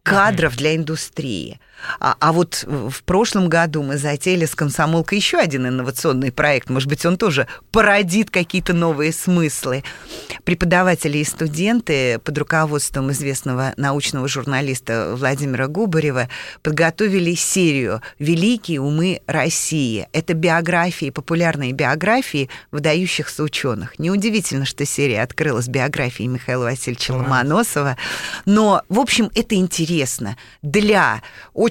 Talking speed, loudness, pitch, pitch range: 115 wpm, -18 LUFS, 155 Hz, 135-180 Hz